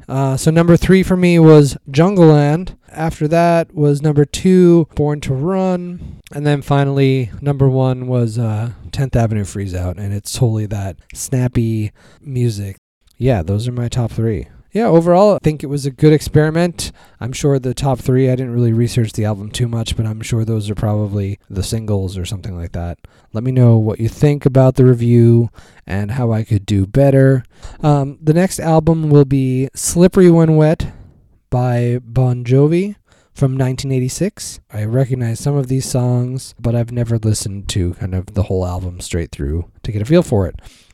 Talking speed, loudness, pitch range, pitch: 185 wpm, -15 LUFS, 105-145 Hz, 125 Hz